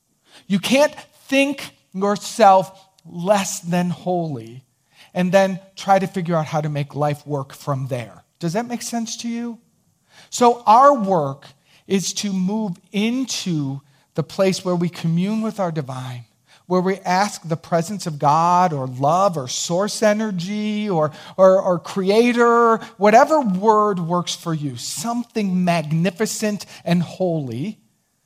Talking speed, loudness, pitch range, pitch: 140 wpm, -19 LUFS, 155-210 Hz, 185 Hz